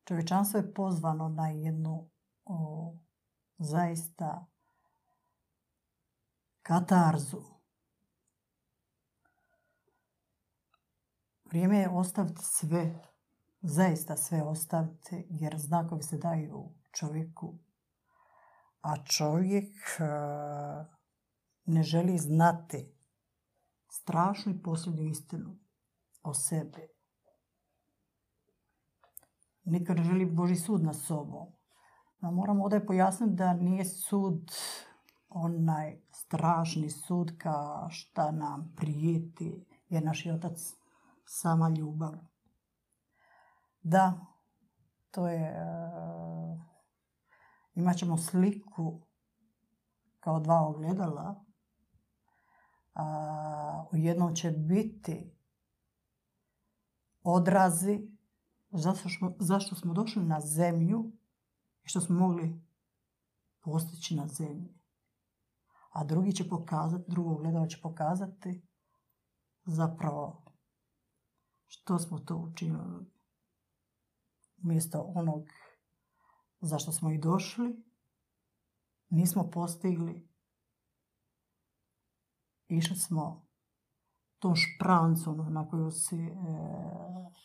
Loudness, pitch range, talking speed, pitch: -32 LUFS, 160-185 Hz, 80 wpm, 170 Hz